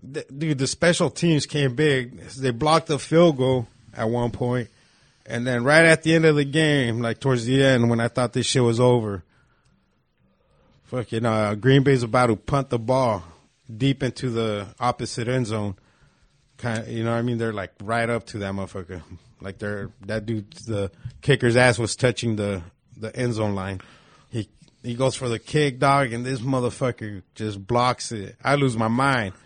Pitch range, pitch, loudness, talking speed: 110-135 Hz, 120 Hz, -22 LUFS, 195 wpm